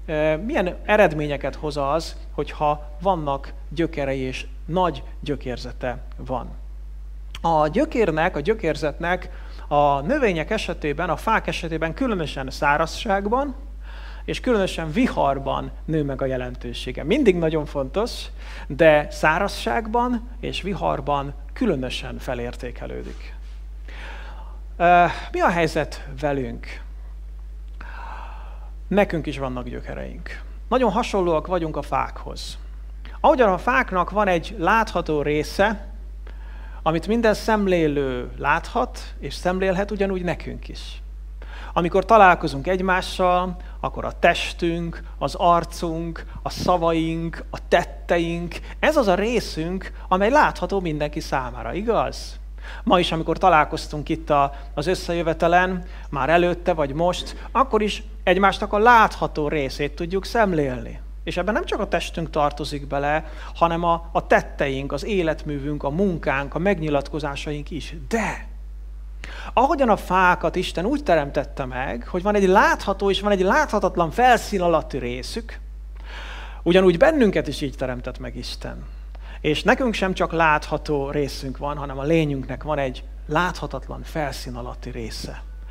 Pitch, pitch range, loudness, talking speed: 155 Hz, 135-185 Hz, -22 LUFS, 120 wpm